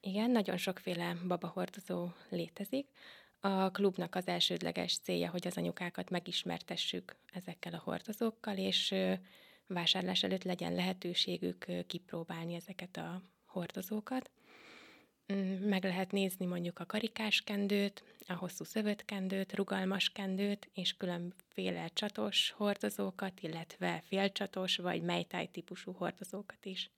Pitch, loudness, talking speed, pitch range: 190 Hz, -37 LUFS, 110 wpm, 175-200 Hz